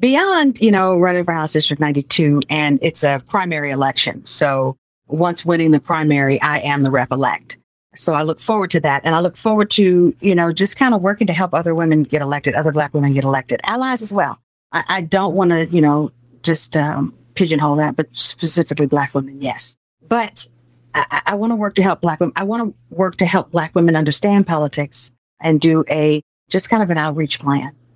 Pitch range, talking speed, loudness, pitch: 145-185 Hz, 210 wpm, -17 LUFS, 155 Hz